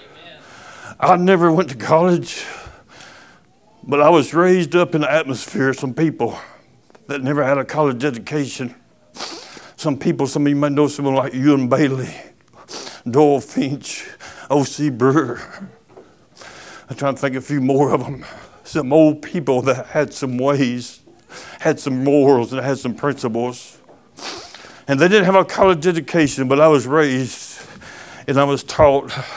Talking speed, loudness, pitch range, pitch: 155 wpm, -17 LUFS, 135-155 Hz, 140 Hz